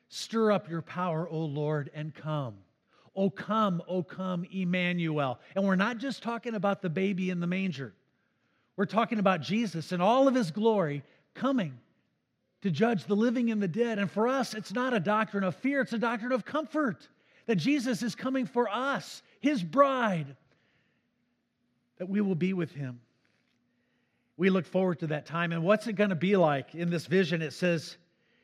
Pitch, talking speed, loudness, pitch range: 190 Hz, 185 wpm, -30 LUFS, 165-225 Hz